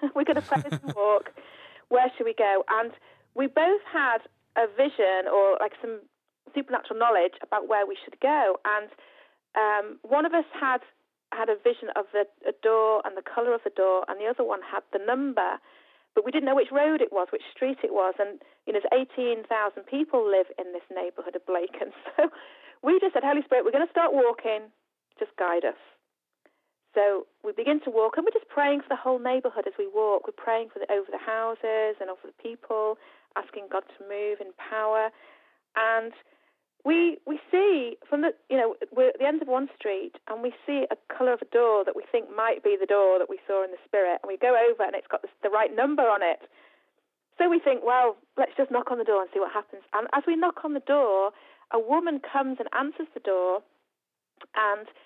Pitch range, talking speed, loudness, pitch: 210-295 Hz, 220 wpm, -26 LUFS, 240 Hz